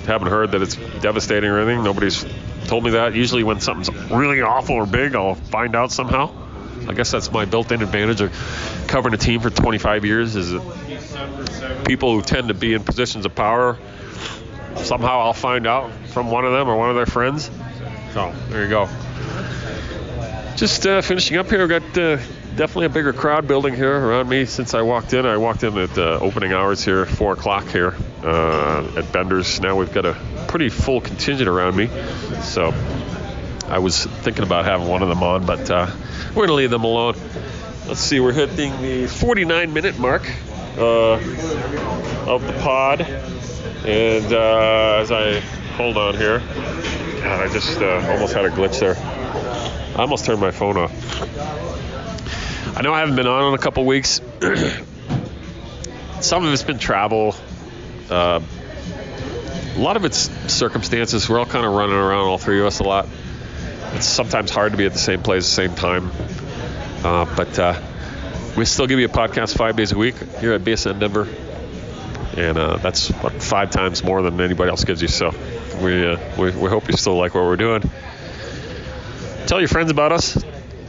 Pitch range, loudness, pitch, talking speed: 95-120 Hz, -19 LUFS, 110 Hz, 185 wpm